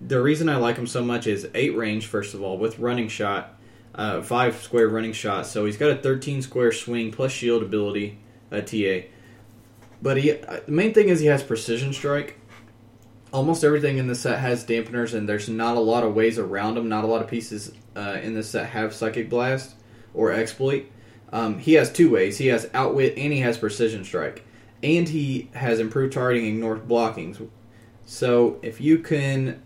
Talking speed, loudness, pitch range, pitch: 195 wpm, -23 LUFS, 110-130 Hz, 115 Hz